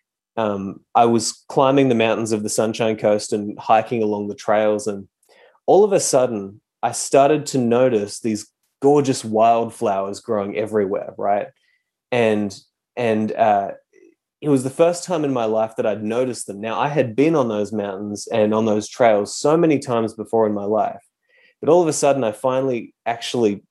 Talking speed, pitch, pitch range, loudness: 180 wpm, 110 Hz, 105-130 Hz, -19 LUFS